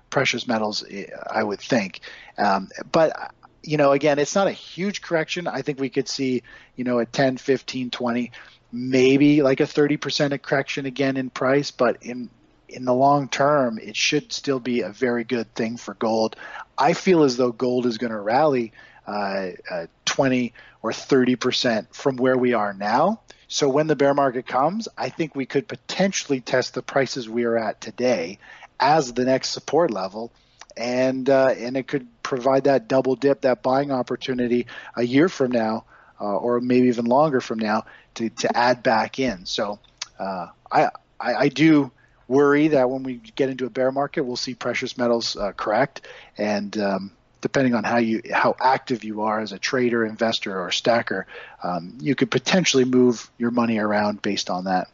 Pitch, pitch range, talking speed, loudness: 125 Hz, 120-140 Hz, 185 wpm, -22 LUFS